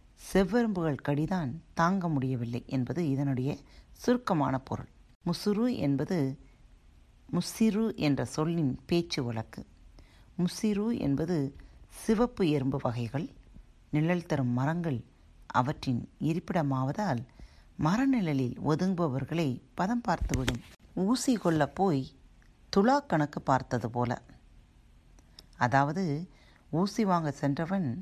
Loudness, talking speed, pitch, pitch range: -30 LUFS, 85 wpm, 150 Hz, 130-180 Hz